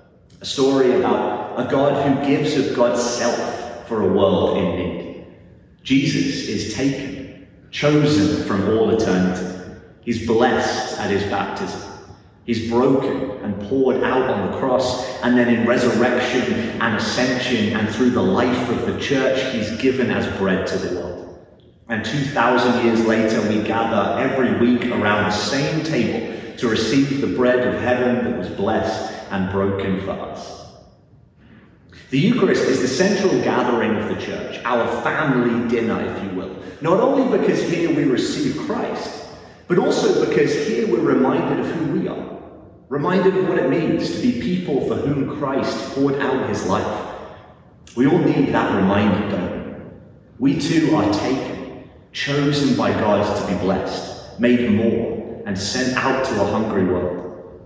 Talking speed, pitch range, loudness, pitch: 160 wpm, 100-130 Hz, -19 LUFS, 120 Hz